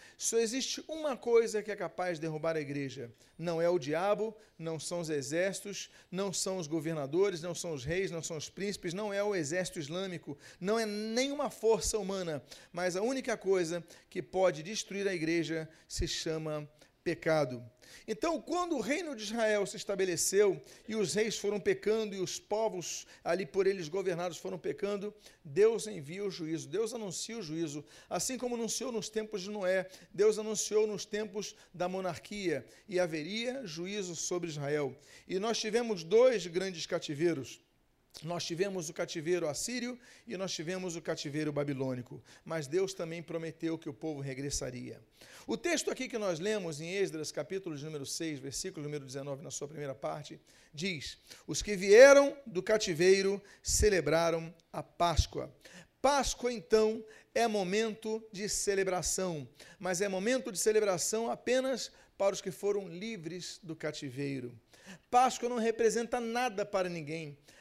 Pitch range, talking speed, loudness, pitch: 165-215 Hz, 160 wpm, -33 LUFS, 185 Hz